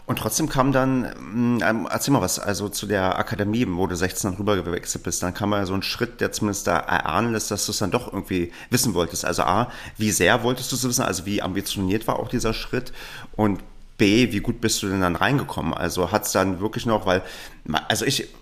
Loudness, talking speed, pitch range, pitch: -23 LUFS, 230 wpm, 95-115 Hz, 105 Hz